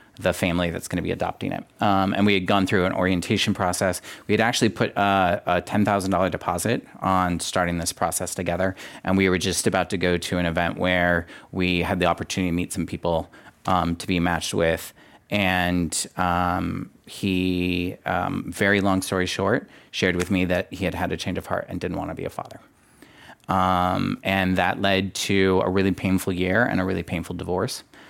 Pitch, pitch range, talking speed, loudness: 90 Hz, 90-95 Hz, 200 wpm, -23 LUFS